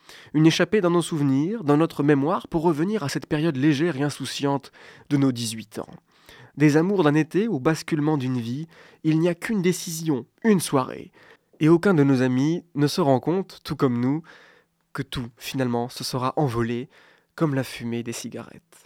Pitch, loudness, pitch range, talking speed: 150 Hz, -23 LUFS, 130-165 Hz, 185 wpm